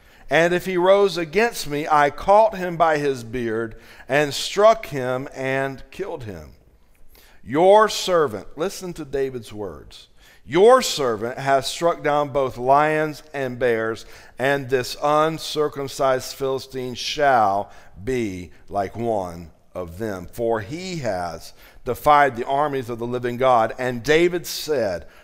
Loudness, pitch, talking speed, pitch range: -21 LUFS, 135 Hz, 135 wpm, 120-155 Hz